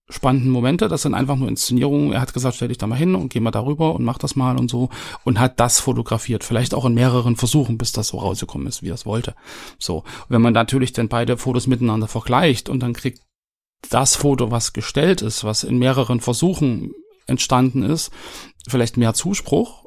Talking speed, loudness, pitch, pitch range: 210 wpm, -19 LUFS, 125 Hz, 120-135 Hz